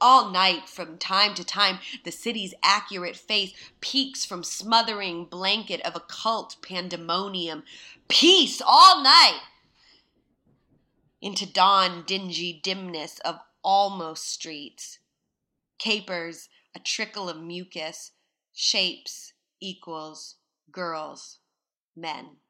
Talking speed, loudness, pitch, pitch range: 95 wpm, -22 LUFS, 185 Hz, 170-210 Hz